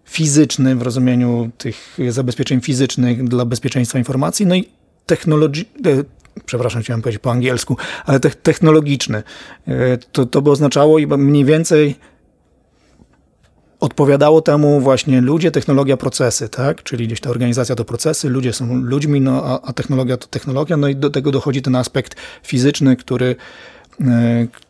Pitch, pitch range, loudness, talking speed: 135 Hz, 125-145 Hz, -15 LUFS, 135 wpm